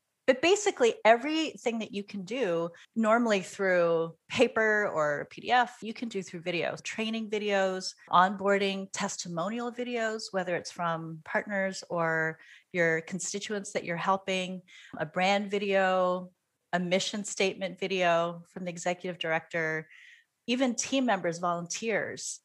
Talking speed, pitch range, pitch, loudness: 125 wpm, 175-220 Hz, 195 Hz, -29 LUFS